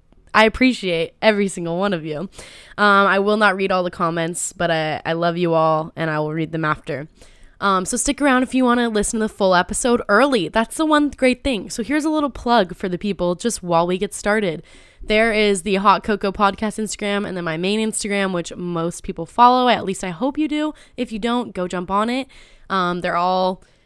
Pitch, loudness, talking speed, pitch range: 200 Hz, -19 LUFS, 230 wpm, 175-230 Hz